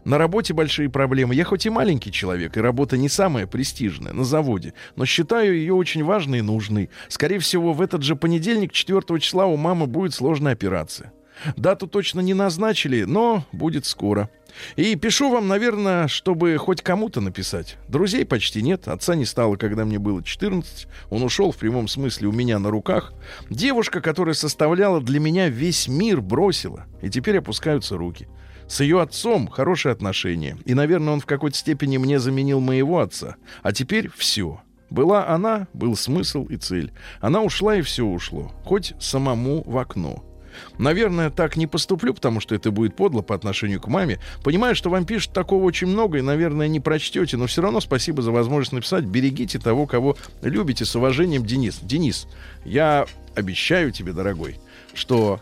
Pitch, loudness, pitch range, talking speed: 145 Hz, -21 LUFS, 115-180 Hz, 170 wpm